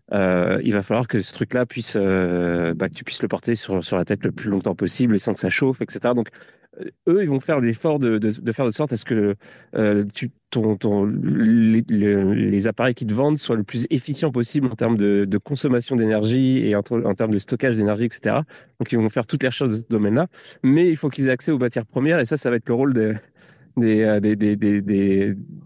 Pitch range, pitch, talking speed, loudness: 105-130 Hz, 115 Hz, 245 wpm, -20 LUFS